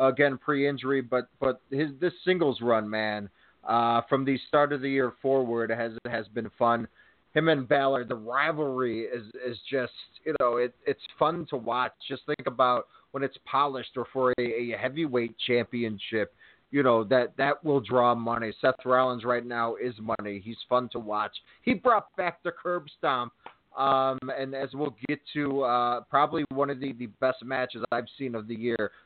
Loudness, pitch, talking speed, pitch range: -28 LUFS, 130 Hz, 190 wpm, 120-140 Hz